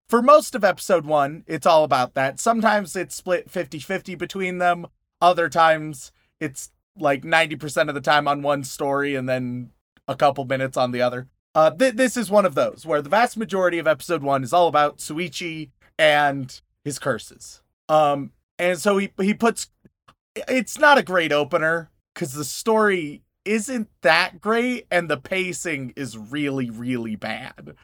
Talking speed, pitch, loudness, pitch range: 170 wpm, 160 Hz, -21 LUFS, 145-190 Hz